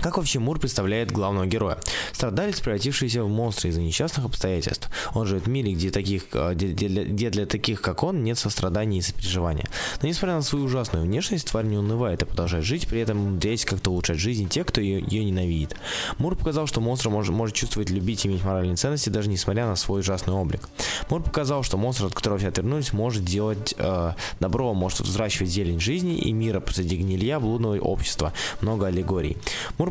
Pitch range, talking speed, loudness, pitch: 95-115 Hz, 190 wpm, -25 LUFS, 105 Hz